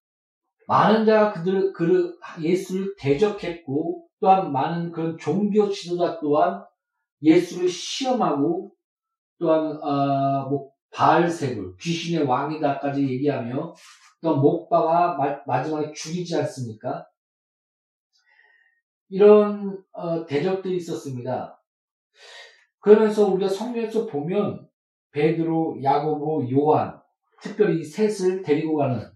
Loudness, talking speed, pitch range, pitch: -22 LUFS, 235 characters per minute, 150-210 Hz, 170 Hz